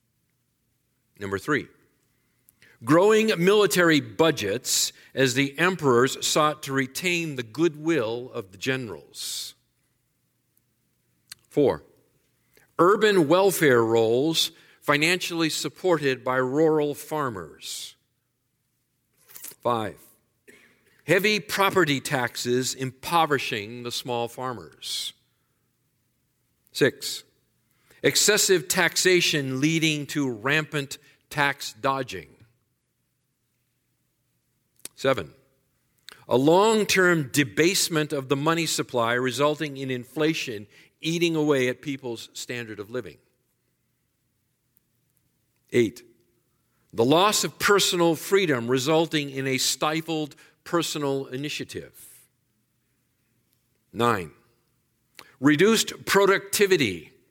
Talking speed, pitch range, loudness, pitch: 80 wpm, 125-160 Hz, -23 LUFS, 135 Hz